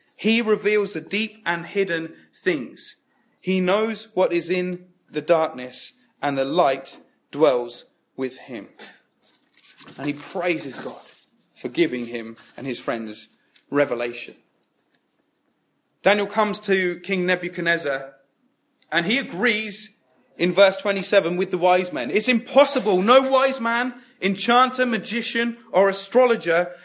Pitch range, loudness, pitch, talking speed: 165-225 Hz, -22 LUFS, 190 Hz, 125 wpm